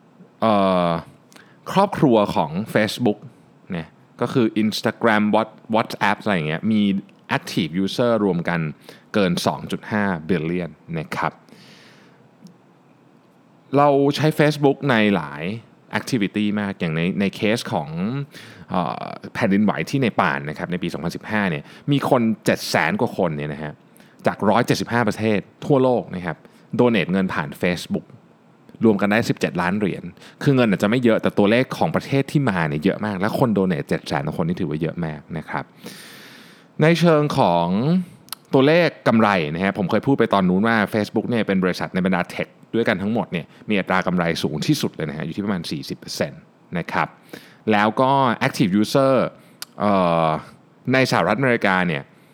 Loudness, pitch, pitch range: -21 LUFS, 110 Hz, 95-140 Hz